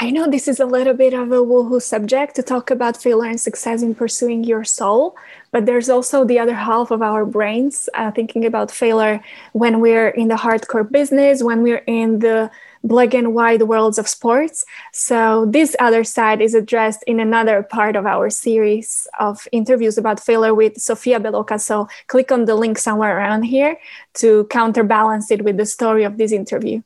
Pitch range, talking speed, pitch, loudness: 220-245 Hz, 190 wpm, 230 Hz, -16 LUFS